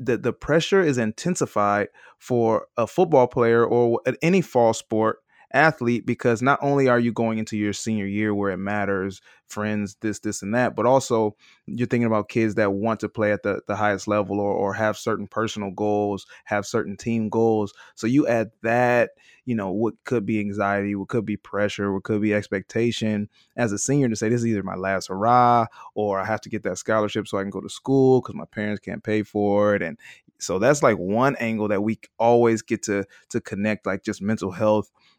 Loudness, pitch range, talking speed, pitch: -23 LUFS, 105-120 Hz, 210 wpm, 110 Hz